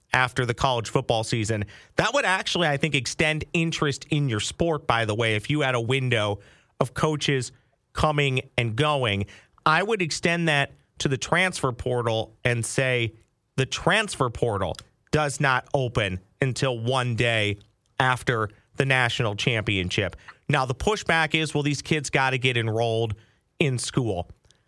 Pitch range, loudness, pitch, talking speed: 115-145 Hz, -24 LUFS, 130 Hz, 155 wpm